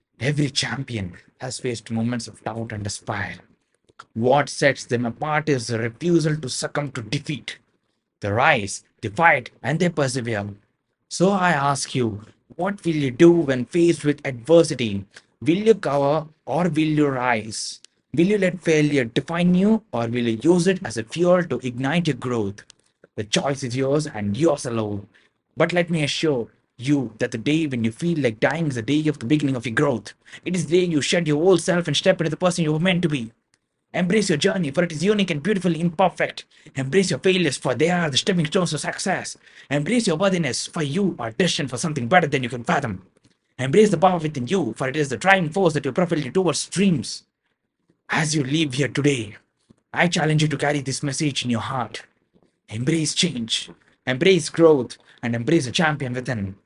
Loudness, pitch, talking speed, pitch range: -21 LUFS, 150 Hz, 200 wpm, 125-170 Hz